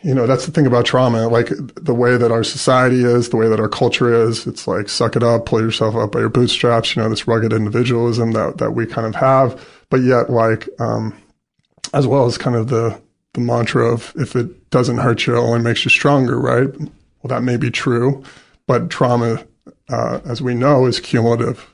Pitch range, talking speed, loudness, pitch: 115-130 Hz, 220 wpm, -16 LUFS, 120 Hz